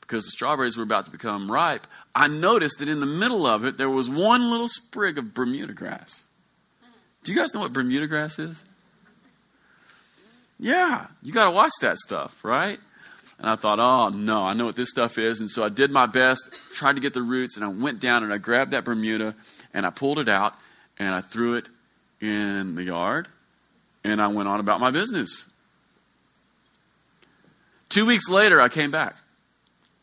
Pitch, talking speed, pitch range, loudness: 125 Hz, 190 wpm, 110-155 Hz, -23 LUFS